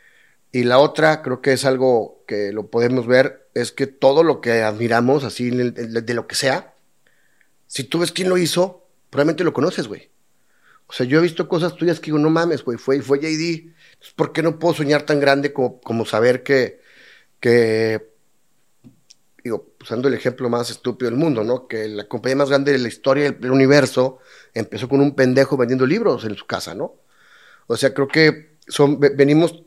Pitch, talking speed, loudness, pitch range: 135 Hz, 190 wpm, -18 LUFS, 125-155 Hz